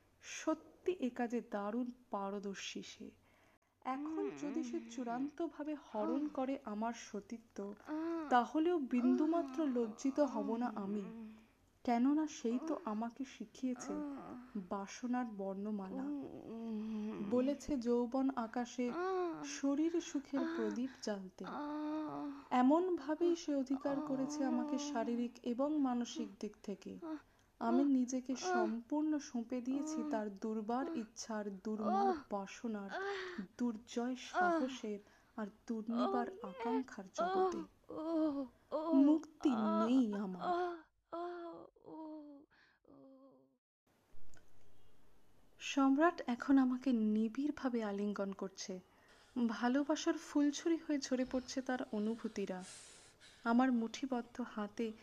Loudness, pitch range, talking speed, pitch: -39 LUFS, 220-295 Hz, 85 wpm, 255 Hz